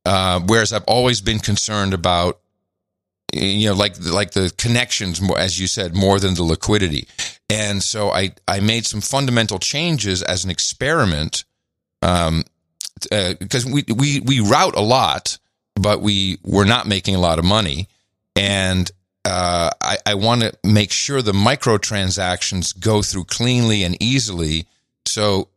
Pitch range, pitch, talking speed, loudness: 90-110 Hz, 100 Hz, 155 wpm, -18 LUFS